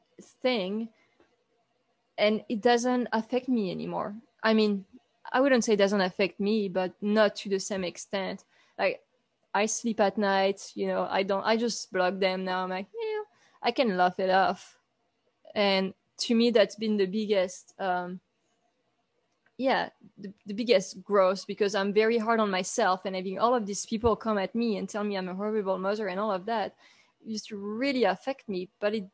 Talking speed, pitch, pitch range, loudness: 185 wpm, 210 Hz, 190-230 Hz, -28 LUFS